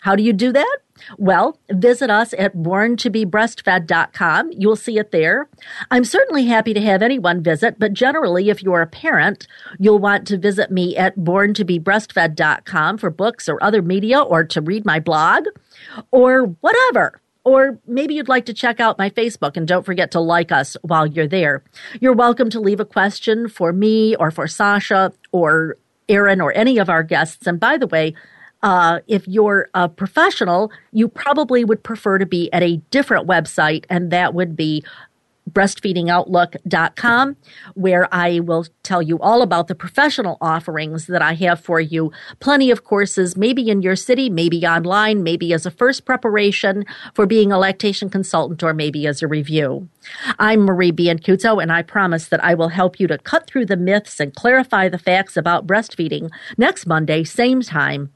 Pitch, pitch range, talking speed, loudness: 195 Hz, 170-225 Hz, 175 wpm, -16 LUFS